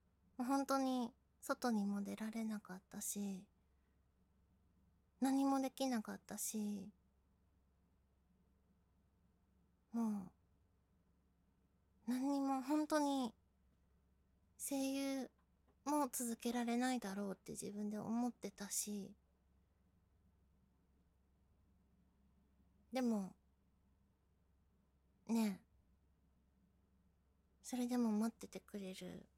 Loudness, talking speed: -42 LUFS, 140 characters per minute